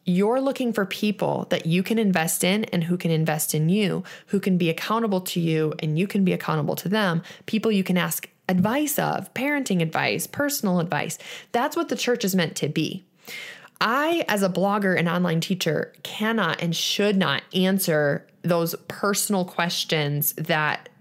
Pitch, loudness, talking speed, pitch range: 185 Hz, -23 LUFS, 175 wpm, 165-210 Hz